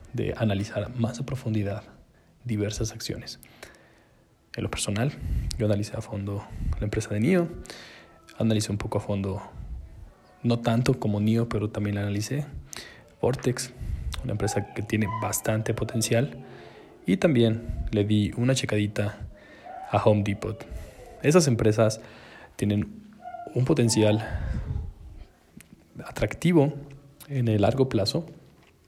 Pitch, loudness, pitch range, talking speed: 110 Hz, -27 LUFS, 105-120 Hz, 120 wpm